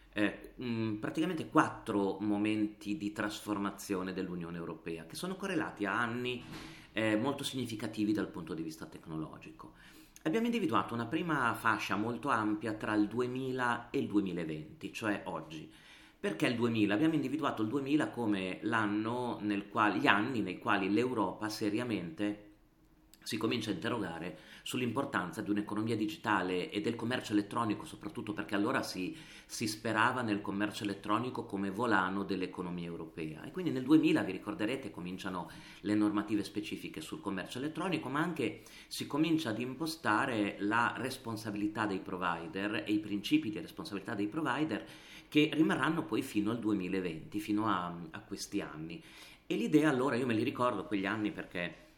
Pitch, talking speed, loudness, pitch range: 105 Hz, 150 wpm, -35 LUFS, 100-120 Hz